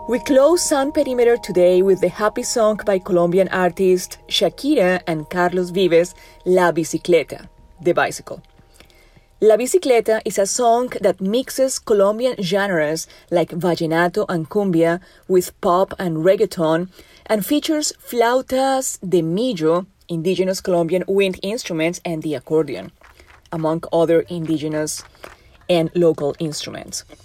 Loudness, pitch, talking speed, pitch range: -18 LUFS, 185 Hz, 120 wpm, 170-220 Hz